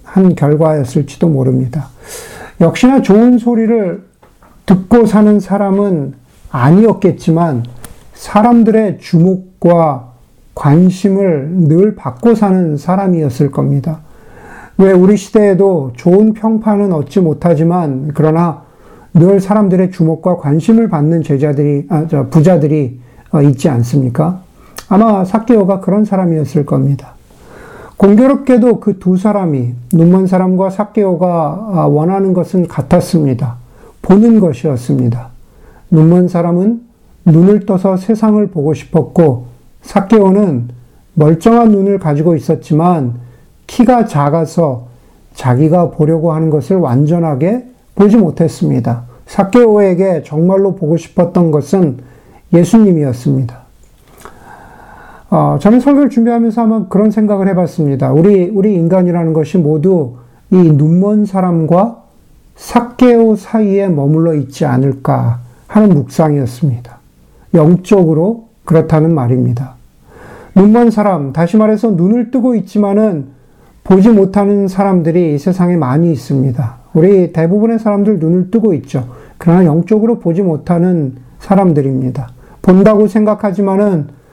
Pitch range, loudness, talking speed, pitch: 145-200 Hz, -11 LUFS, 280 characters per minute, 175 Hz